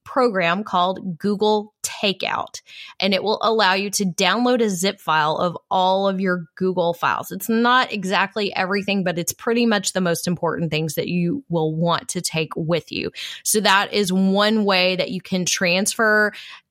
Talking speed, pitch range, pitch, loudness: 175 wpm, 175-210 Hz, 190 Hz, -20 LUFS